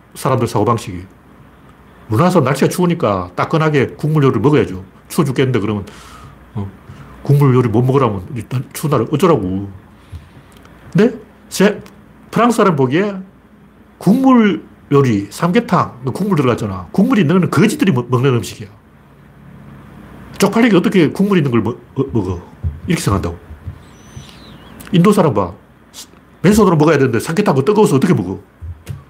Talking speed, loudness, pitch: 320 characters per minute, -14 LUFS, 135 Hz